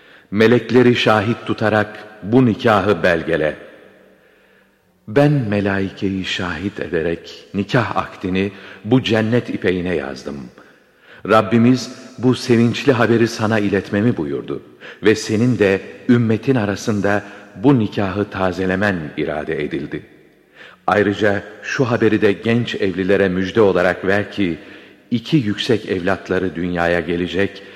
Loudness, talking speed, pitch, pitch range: -17 LUFS, 105 wpm, 105 Hz, 95-120 Hz